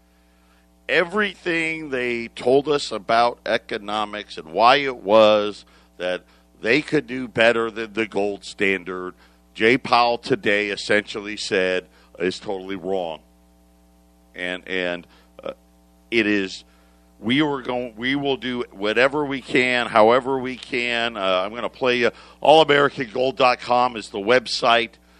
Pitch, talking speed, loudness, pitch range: 105 Hz, 130 wpm, -21 LUFS, 90-125 Hz